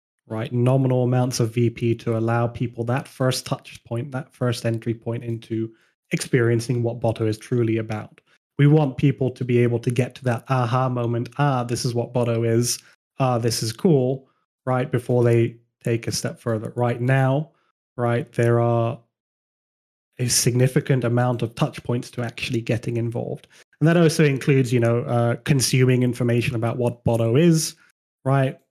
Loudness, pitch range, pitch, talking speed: -22 LUFS, 115-130 Hz, 120 Hz, 170 wpm